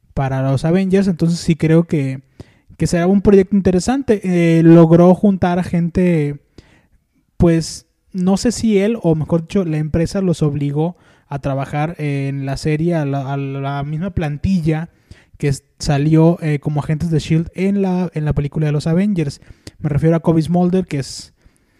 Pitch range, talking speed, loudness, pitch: 145-180 Hz, 170 wpm, -16 LUFS, 160 Hz